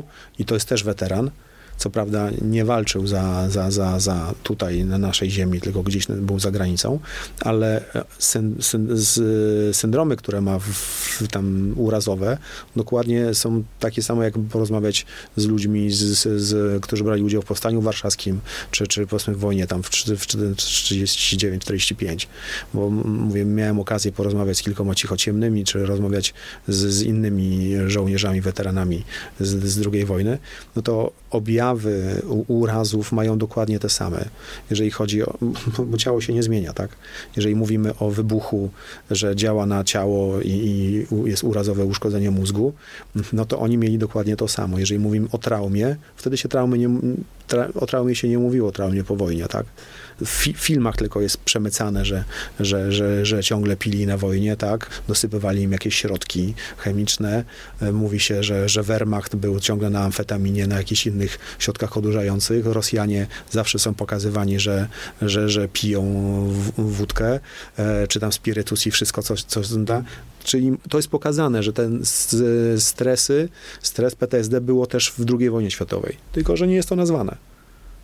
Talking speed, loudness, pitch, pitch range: 155 wpm, -21 LUFS, 105 Hz, 100-115 Hz